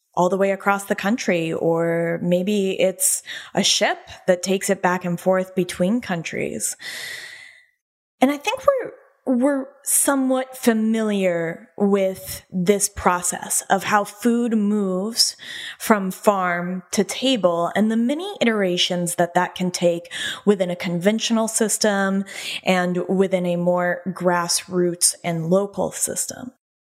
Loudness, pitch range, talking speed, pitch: -21 LUFS, 180-225 Hz, 125 wpm, 195 Hz